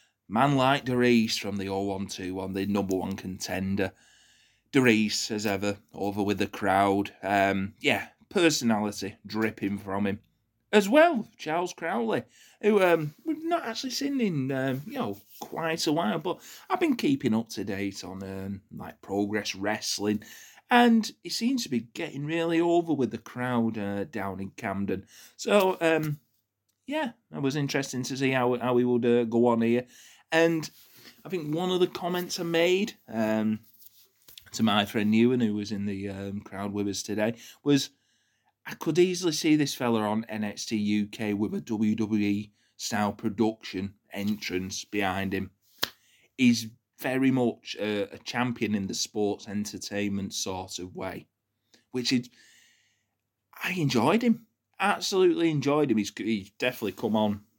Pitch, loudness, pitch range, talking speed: 115 Hz, -28 LUFS, 100-150 Hz, 155 wpm